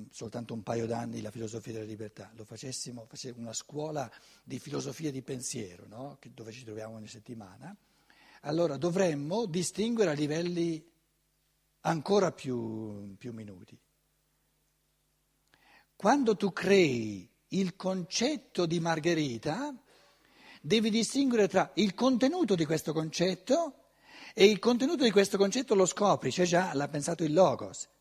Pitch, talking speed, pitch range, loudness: 160 Hz, 130 wpm, 115-195 Hz, -30 LUFS